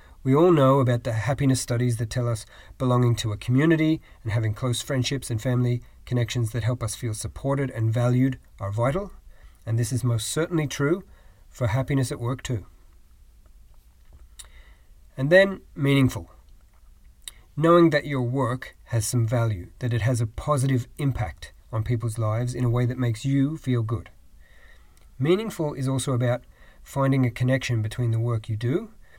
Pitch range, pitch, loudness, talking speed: 115-135 Hz, 125 Hz, -24 LUFS, 165 wpm